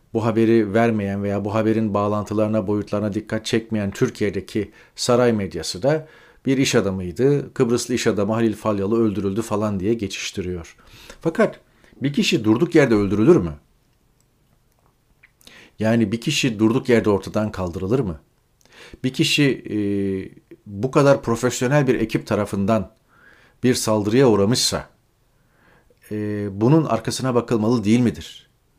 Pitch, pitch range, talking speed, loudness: 115 Hz, 105-125 Hz, 125 wpm, -20 LUFS